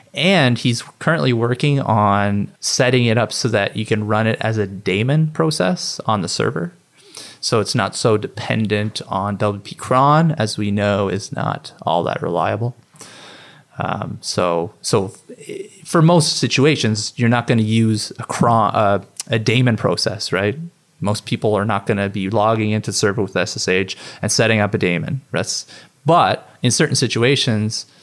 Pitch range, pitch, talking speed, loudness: 105-130 Hz, 110 Hz, 165 wpm, -18 LUFS